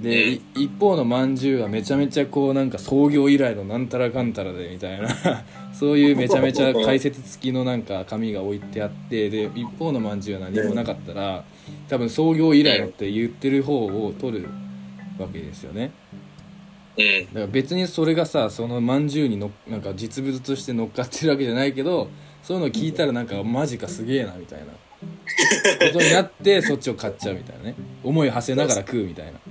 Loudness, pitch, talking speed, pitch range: -22 LUFS, 125 Hz, 405 characters per minute, 105-145 Hz